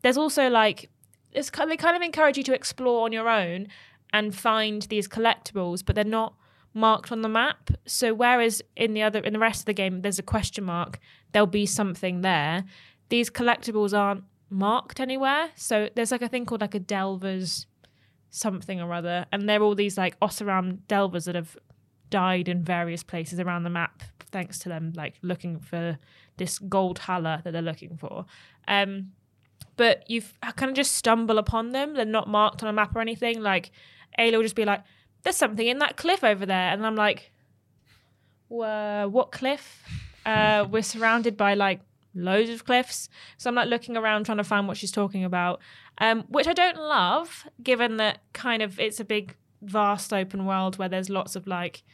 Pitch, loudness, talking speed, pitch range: 205 Hz, -25 LUFS, 195 wpm, 180-230 Hz